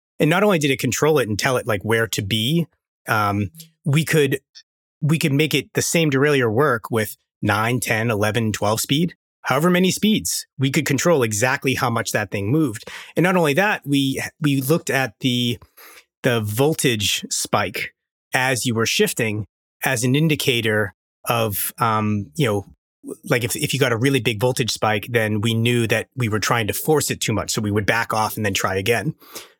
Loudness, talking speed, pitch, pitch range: -20 LUFS, 195 wpm, 125 Hz, 110-145 Hz